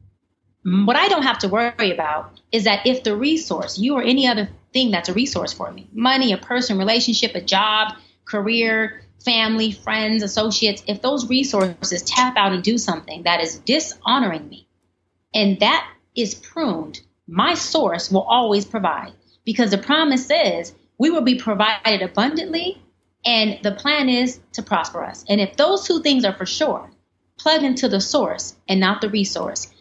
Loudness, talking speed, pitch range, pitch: -19 LUFS, 170 wpm, 195-255 Hz, 220 Hz